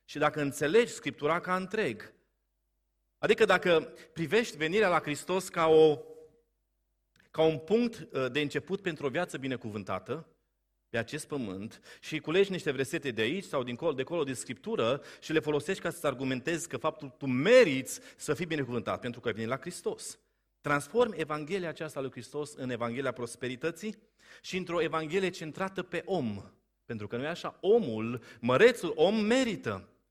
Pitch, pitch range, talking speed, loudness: 155 Hz, 130-180 Hz, 160 wpm, -31 LUFS